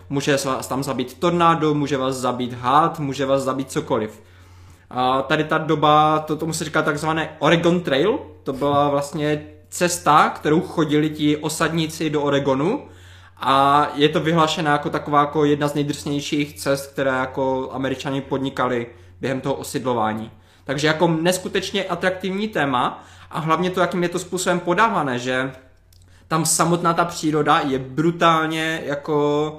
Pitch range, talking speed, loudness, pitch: 130-160 Hz, 150 wpm, -20 LUFS, 145 Hz